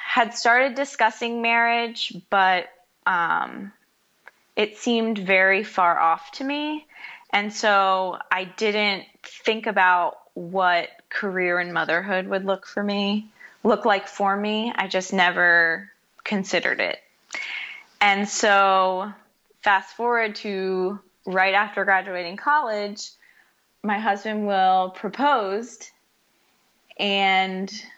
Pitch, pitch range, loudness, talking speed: 200 Hz, 185-220 Hz, -22 LUFS, 105 wpm